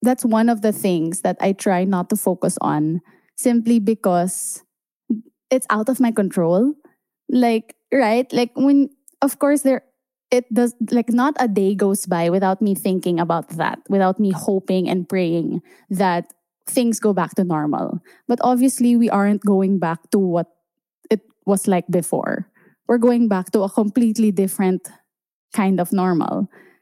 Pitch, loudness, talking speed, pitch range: 210 Hz, -19 LUFS, 160 wpm, 185-245 Hz